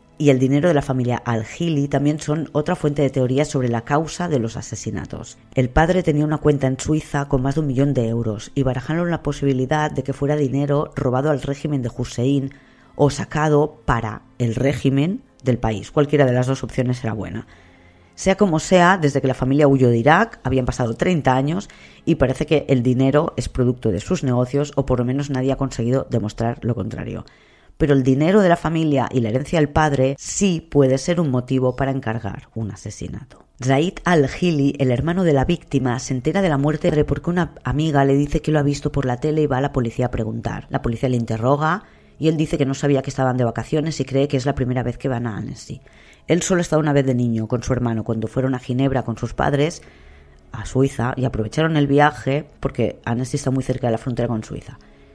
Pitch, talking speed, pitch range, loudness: 135 Hz, 225 wpm, 125-150 Hz, -20 LUFS